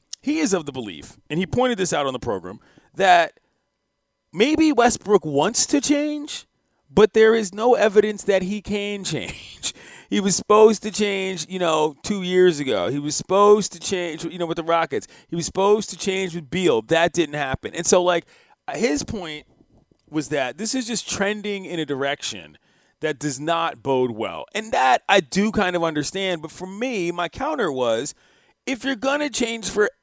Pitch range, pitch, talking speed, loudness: 165-215 Hz, 190 Hz, 190 wpm, -21 LUFS